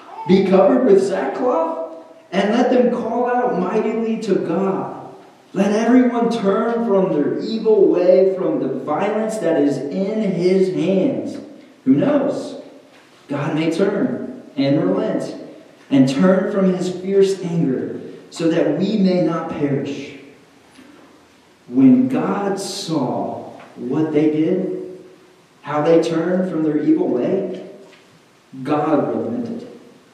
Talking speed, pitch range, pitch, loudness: 120 wpm, 160-230 Hz, 190 Hz, -18 LUFS